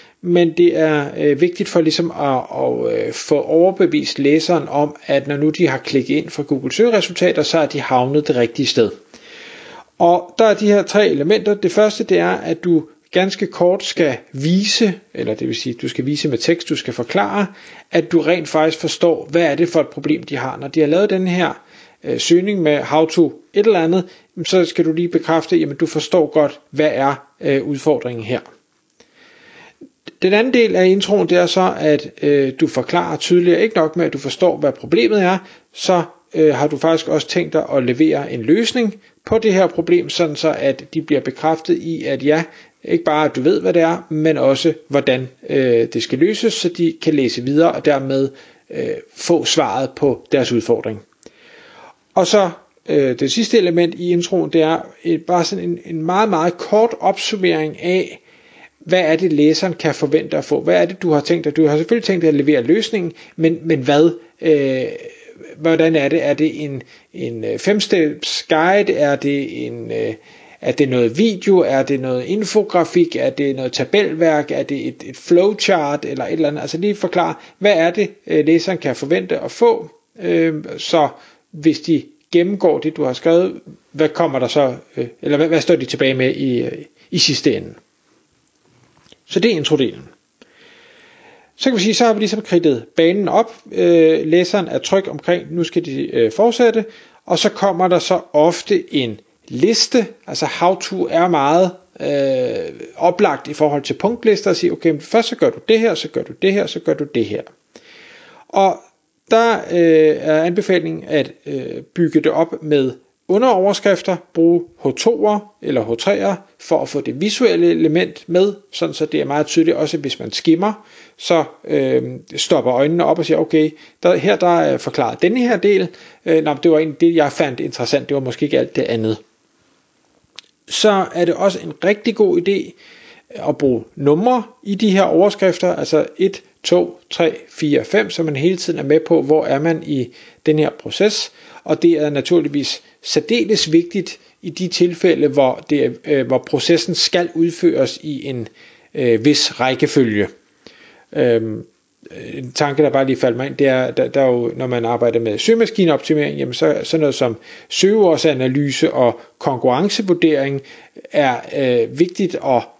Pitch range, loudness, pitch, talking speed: 150-190 Hz, -16 LUFS, 165 Hz, 190 wpm